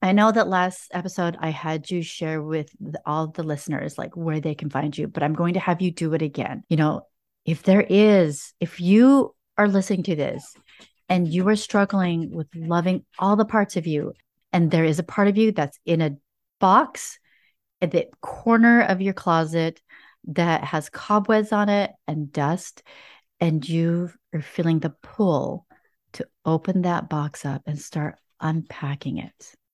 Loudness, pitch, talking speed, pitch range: -22 LUFS, 170 Hz, 180 wpm, 155-195 Hz